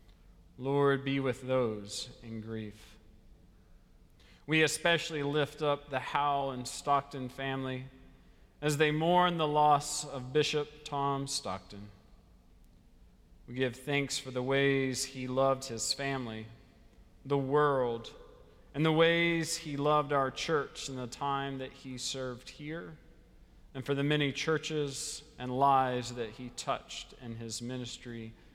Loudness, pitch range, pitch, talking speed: -32 LUFS, 120-145 Hz, 135 Hz, 130 wpm